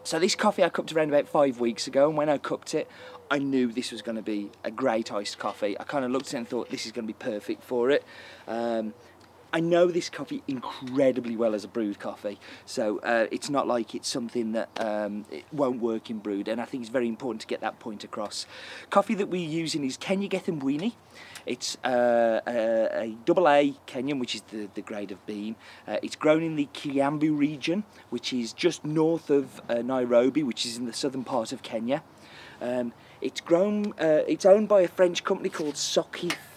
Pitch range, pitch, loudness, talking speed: 115-175 Hz, 140 Hz, -27 LUFS, 220 wpm